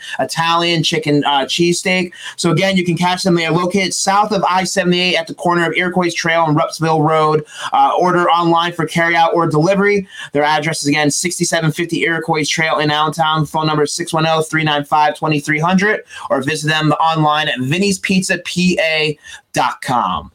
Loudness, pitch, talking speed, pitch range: -15 LUFS, 165 Hz, 145 wpm, 155-180 Hz